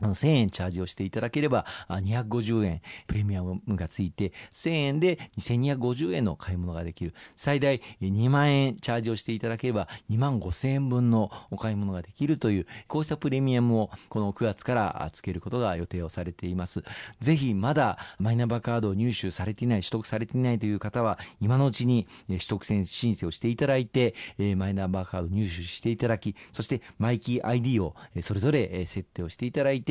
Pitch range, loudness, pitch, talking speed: 95-125 Hz, -28 LUFS, 110 Hz, 385 characters per minute